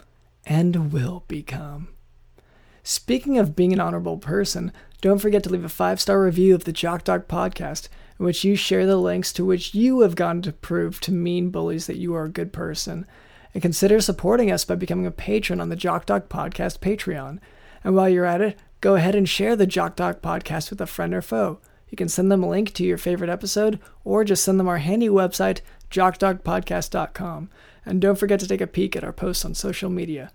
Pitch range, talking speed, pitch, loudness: 165-195 Hz, 210 wpm, 180 Hz, -22 LUFS